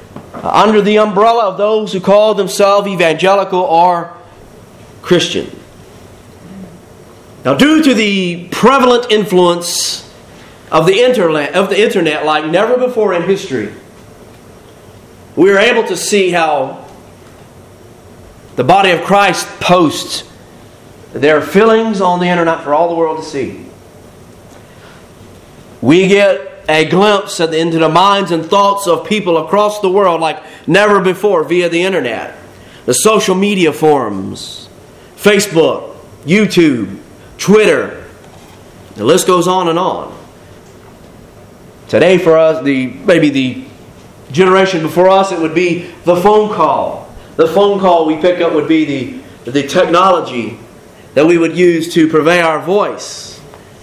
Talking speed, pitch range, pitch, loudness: 130 wpm, 160-200 Hz, 180 Hz, -11 LUFS